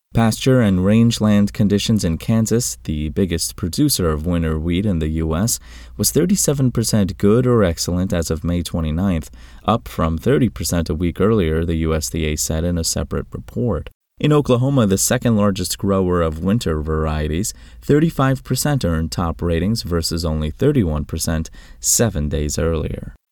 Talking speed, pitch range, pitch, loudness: 145 wpm, 80-110 Hz, 90 Hz, -18 LUFS